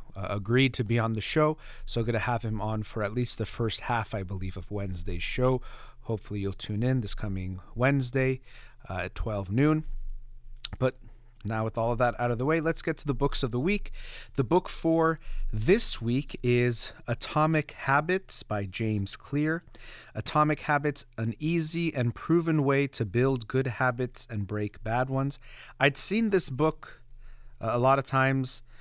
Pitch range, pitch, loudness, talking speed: 110-140 Hz, 125 Hz, -29 LUFS, 180 wpm